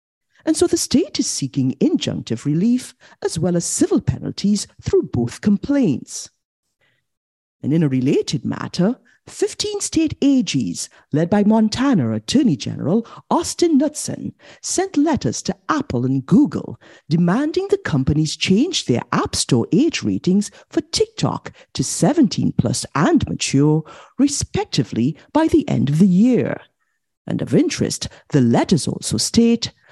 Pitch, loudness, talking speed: 220 Hz, -19 LUFS, 135 wpm